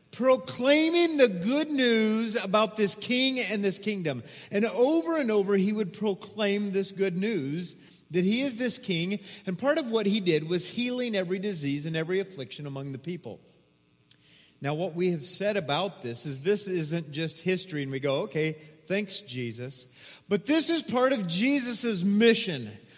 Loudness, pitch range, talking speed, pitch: -26 LUFS, 160-225 Hz, 170 wpm, 195 Hz